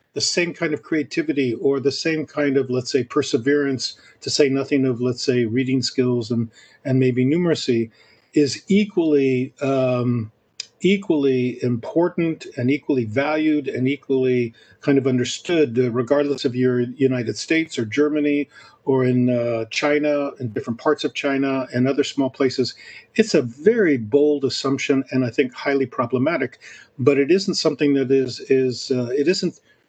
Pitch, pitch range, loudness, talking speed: 135 Hz, 125-150 Hz, -21 LUFS, 160 wpm